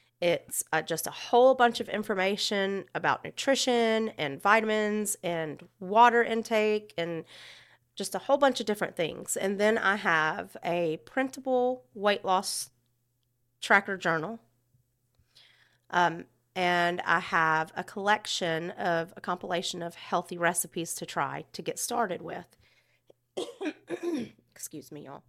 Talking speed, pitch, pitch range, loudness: 130 wpm, 185 Hz, 165-215 Hz, -28 LUFS